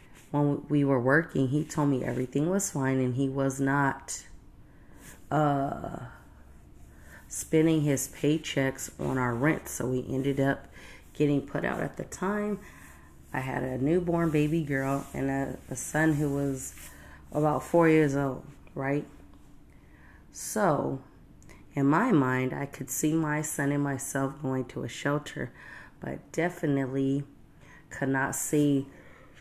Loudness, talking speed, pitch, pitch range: -29 LUFS, 140 wpm, 140 Hz, 130-150 Hz